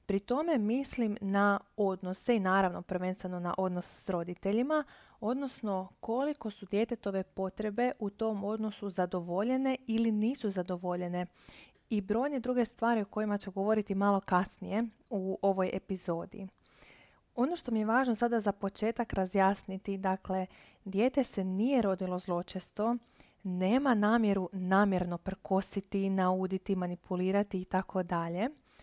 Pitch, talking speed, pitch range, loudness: 200 Hz, 125 wpm, 185-225 Hz, -33 LUFS